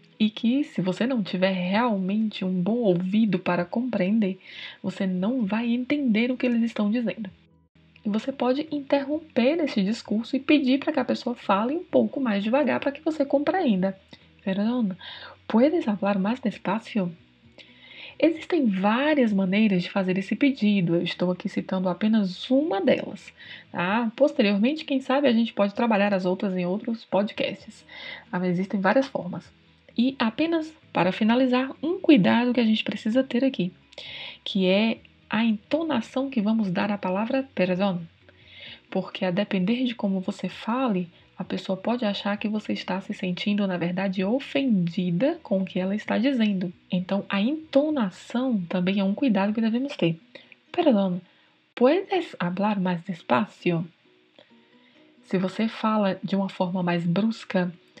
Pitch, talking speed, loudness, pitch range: 215 Hz, 150 wpm, -25 LUFS, 190-255 Hz